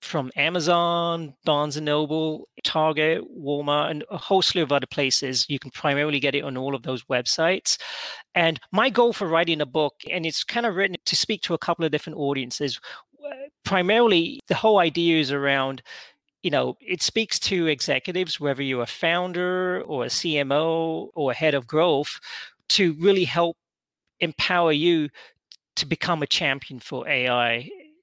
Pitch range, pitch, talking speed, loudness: 140-180 Hz, 160 Hz, 165 wpm, -23 LUFS